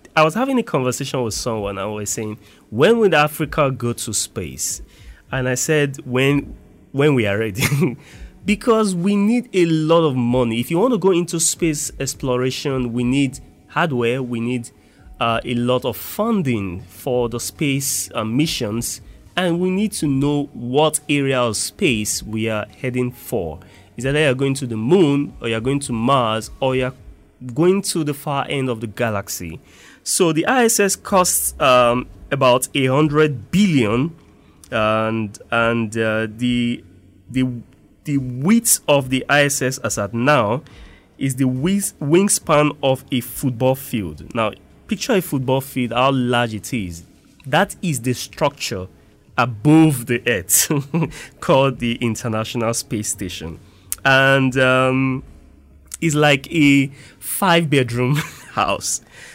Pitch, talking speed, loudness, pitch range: 130 Hz, 150 wpm, -19 LUFS, 115-150 Hz